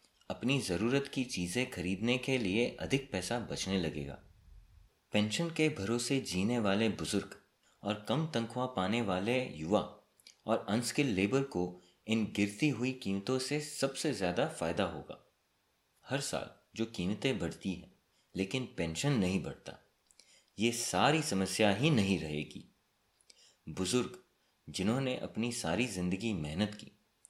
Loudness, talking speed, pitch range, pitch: -34 LUFS, 130 wpm, 95-130 Hz, 110 Hz